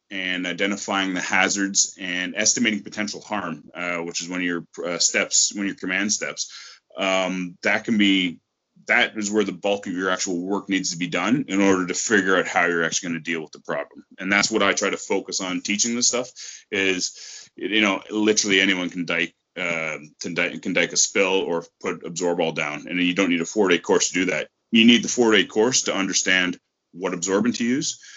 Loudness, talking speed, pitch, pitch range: -21 LUFS, 225 wpm, 95 Hz, 90-105 Hz